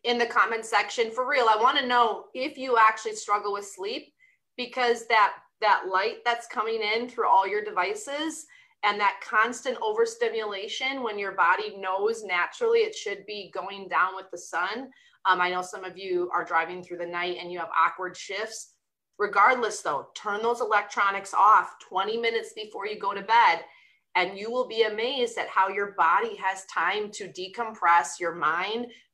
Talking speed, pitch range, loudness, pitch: 180 wpm, 195-265 Hz, -26 LUFS, 220 Hz